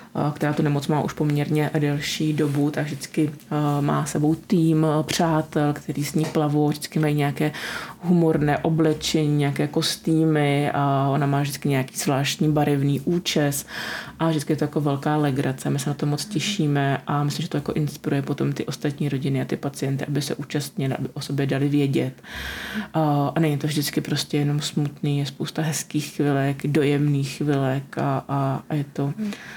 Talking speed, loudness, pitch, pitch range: 175 wpm, -23 LUFS, 150 Hz, 140-155 Hz